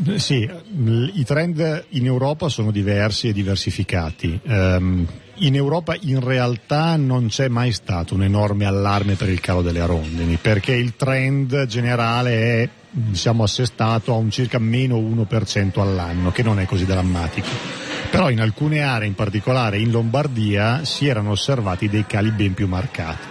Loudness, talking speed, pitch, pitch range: -20 LUFS, 150 wpm, 115 Hz, 100-130 Hz